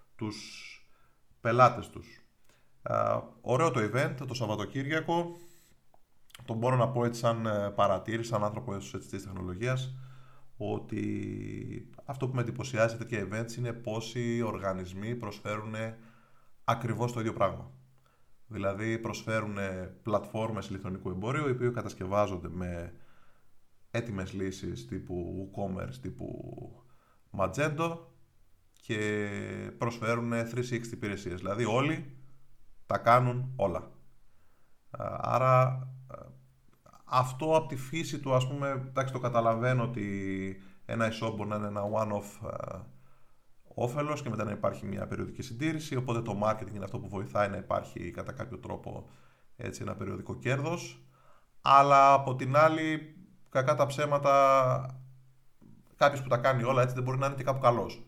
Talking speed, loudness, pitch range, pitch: 125 wpm, -31 LUFS, 105-130 Hz, 115 Hz